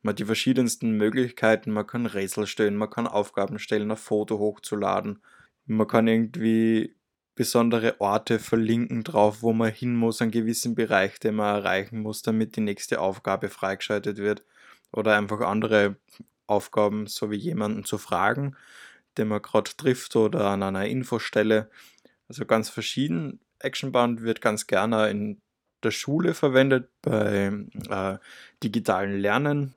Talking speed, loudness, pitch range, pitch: 145 wpm, -25 LUFS, 105-115 Hz, 110 Hz